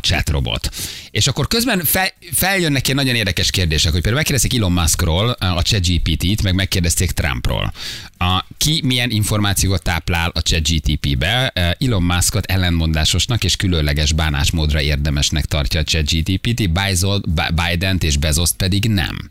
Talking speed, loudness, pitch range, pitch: 145 wpm, -17 LUFS, 80-105 Hz, 90 Hz